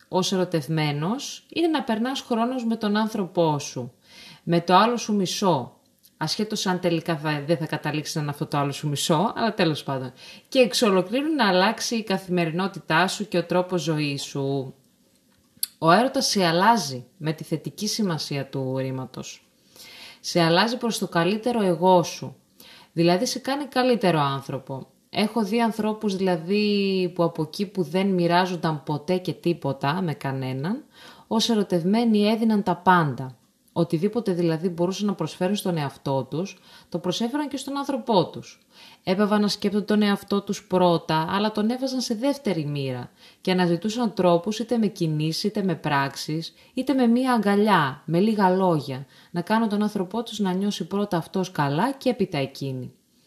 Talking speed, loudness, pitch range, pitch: 160 wpm, -24 LUFS, 160-215 Hz, 185 Hz